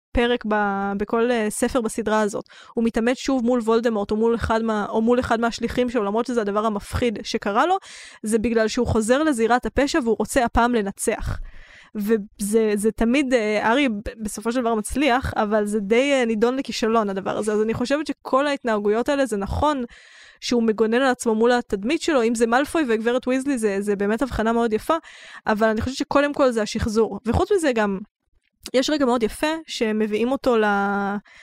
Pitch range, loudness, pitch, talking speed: 215-255 Hz, -22 LUFS, 230 Hz, 175 wpm